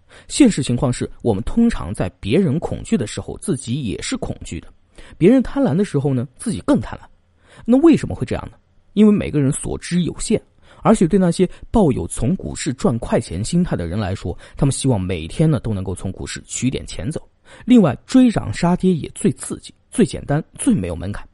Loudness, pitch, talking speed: -19 LUFS, 150 Hz, 305 characters per minute